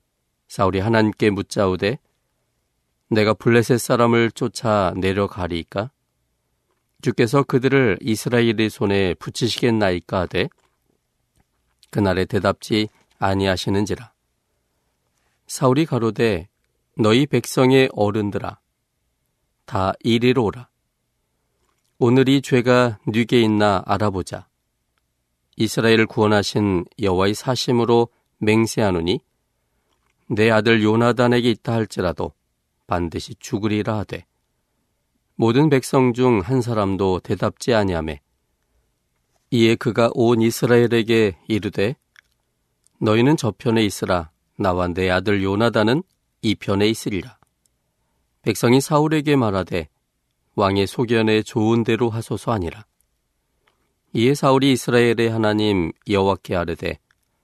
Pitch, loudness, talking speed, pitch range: 110 Hz, -19 LUFS, 250 characters per minute, 95-120 Hz